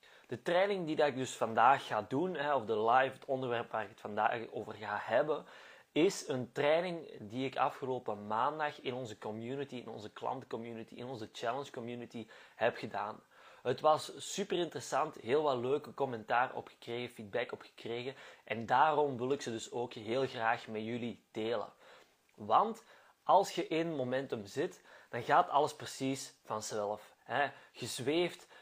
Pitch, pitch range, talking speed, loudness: 125 Hz, 115-145 Hz, 155 wpm, -35 LUFS